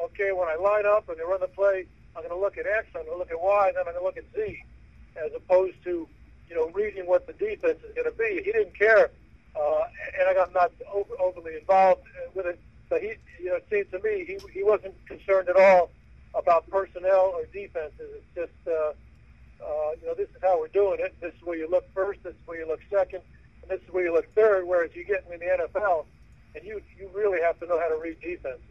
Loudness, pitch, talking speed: -26 LUFS, 195 Hz, 255 wpm